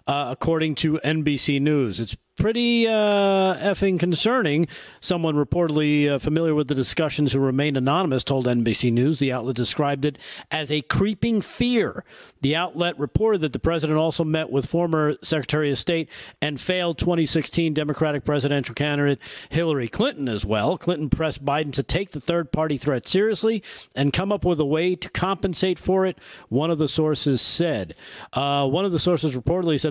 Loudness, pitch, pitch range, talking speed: -22 LUFS, 155 Hz, 140-175 Hz, 175 wpm